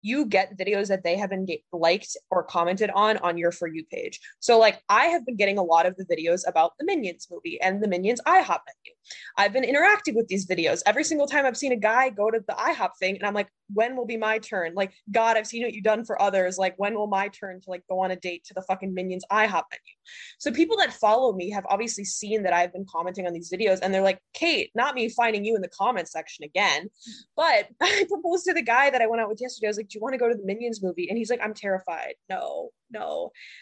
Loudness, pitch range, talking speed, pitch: -25 LUFS, 185-250 Hz, 265 wpm, 210 Hz